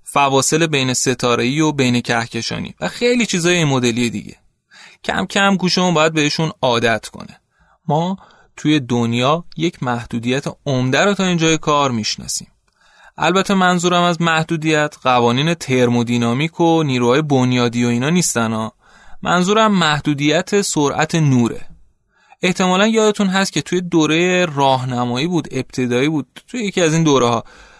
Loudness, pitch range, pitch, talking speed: -16 LUFS, 125-175 Hz, 150 Hz, 135 wpm